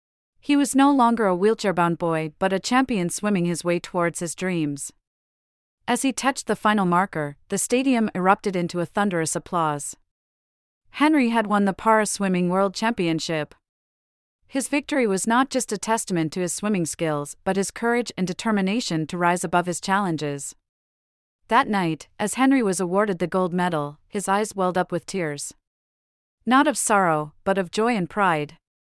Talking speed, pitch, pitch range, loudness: 170 wpm, 185 Hz, 165-215 Hz, -23 LUFS